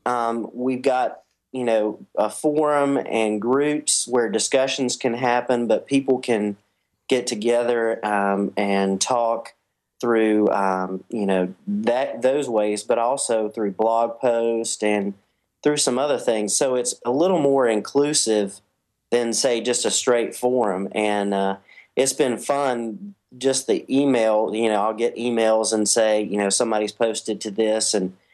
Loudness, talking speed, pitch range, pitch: -21 LUFS, 150 wpm, 105-125 Hz, 115 Hz